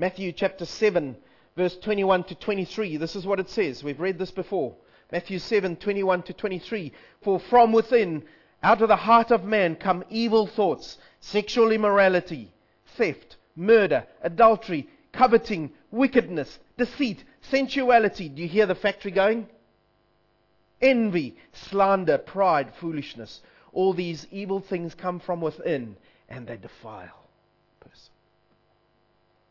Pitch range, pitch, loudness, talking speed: 175-220 Hz, 195 Hz, -24 LUFS, 130 wpm